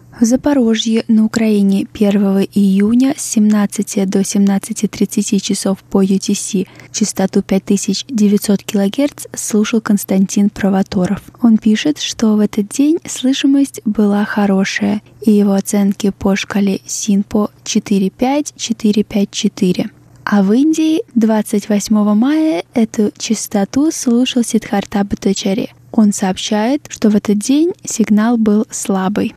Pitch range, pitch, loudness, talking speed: 200-230 Hz, 210 Hz, -14 LUFS, 110 wpm